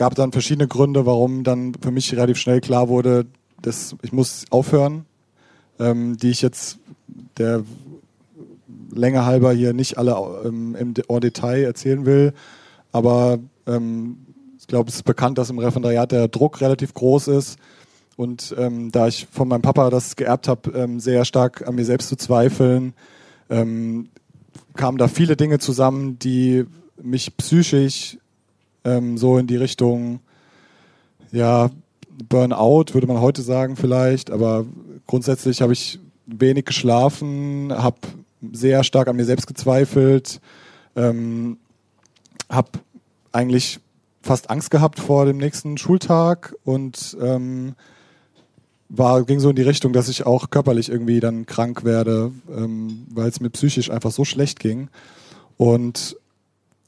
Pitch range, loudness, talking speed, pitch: 120-135 Hz, -19 LUFS, 145 wpm, 125 Hz